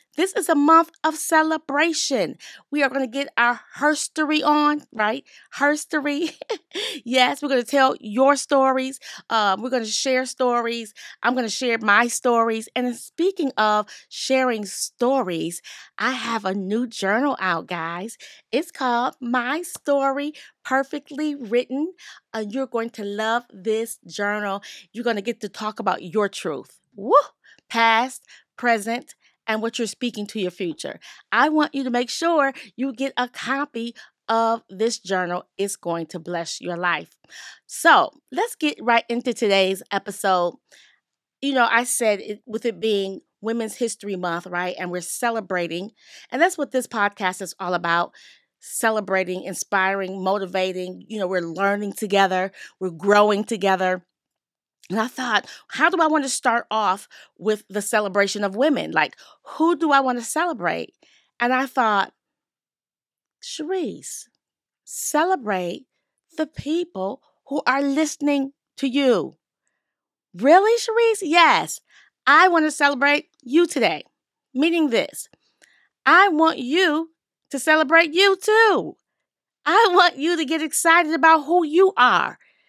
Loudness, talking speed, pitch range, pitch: -21 LUFS, 145 wpm, 205-300 Hz, 245 Hz